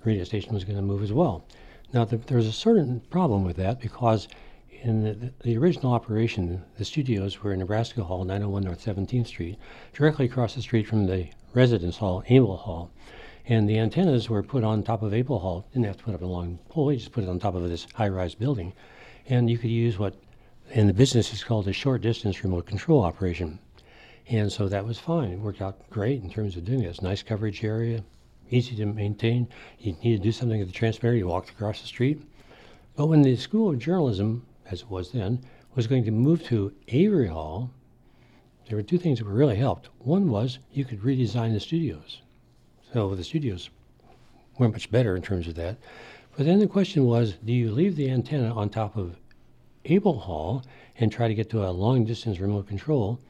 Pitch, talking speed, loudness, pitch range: 115 Hz, 210 wpm, -26 LUFS, 100-125 Hz